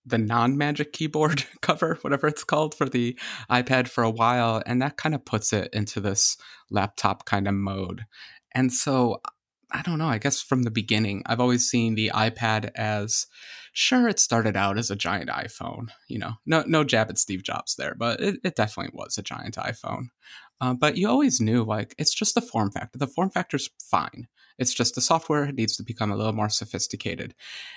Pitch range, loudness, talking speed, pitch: 110-145 Hz, -25 LUFS, 200 wpm, 120 Hz